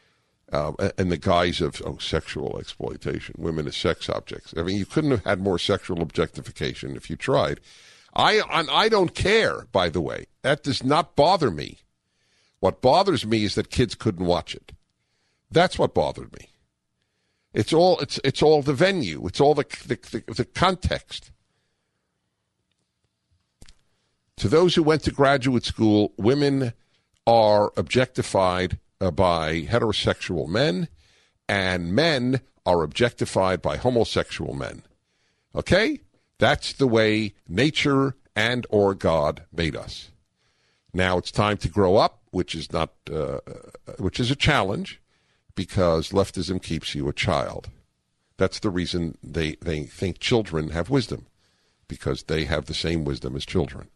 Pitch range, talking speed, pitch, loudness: 85-125 Hz, 145 wpm, 100 Hz, -23 LUFS